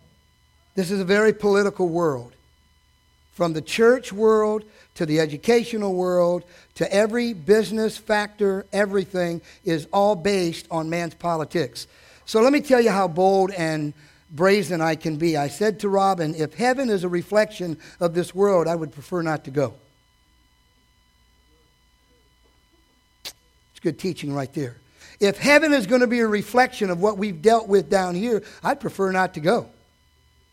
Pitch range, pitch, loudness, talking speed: 150-210 Hz, 180 Hz, -22 LUFS, 155 wpm